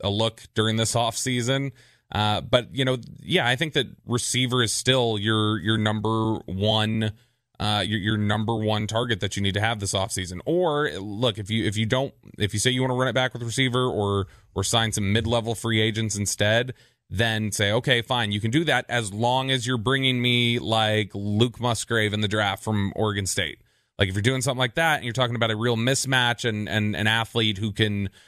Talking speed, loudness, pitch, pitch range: 225 wpm, -24 LUFS, 115 Hz, 105-125 Hz